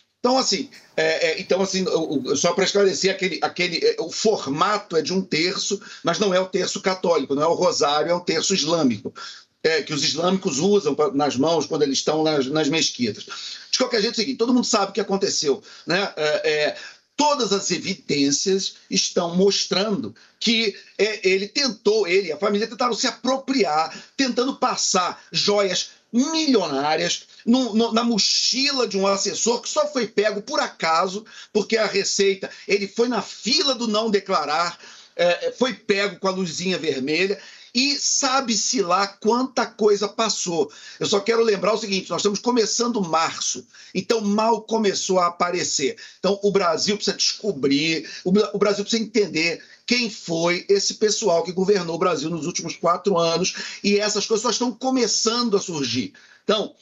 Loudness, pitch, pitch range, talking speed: -21 LUFS, 200 Hz, 180-230 Hz, 175 wpm